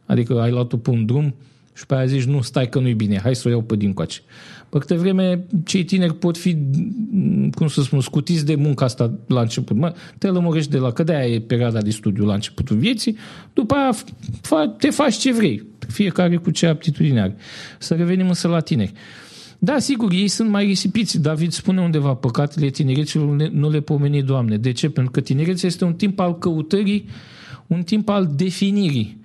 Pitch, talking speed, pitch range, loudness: 160 Hz, 195 wpm, 130-190 Hz, -19 LUFS